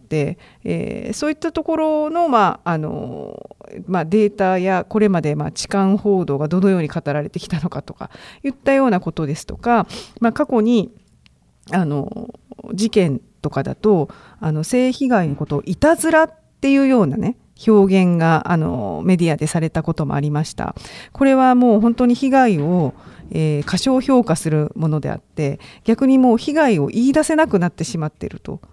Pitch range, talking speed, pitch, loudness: 160-250 Hz, 340 characters per minute, 200 Hz, -18 LUFS